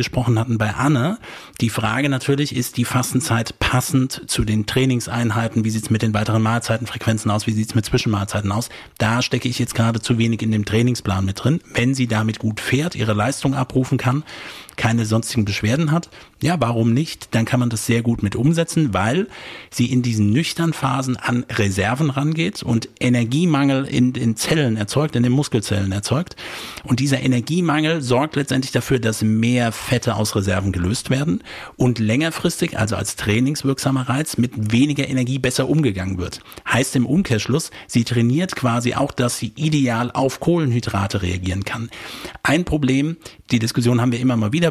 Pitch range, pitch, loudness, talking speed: 110-135 Hz, 120 Hz, -20 LUFS, 175 wpm